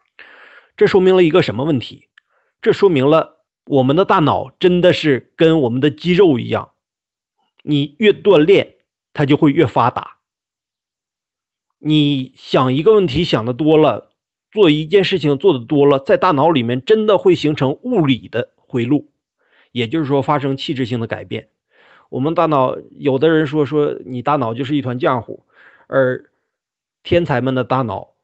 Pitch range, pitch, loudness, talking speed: 130-170 Hz, 150 Hz, -15 LUFS, 235 characters per minute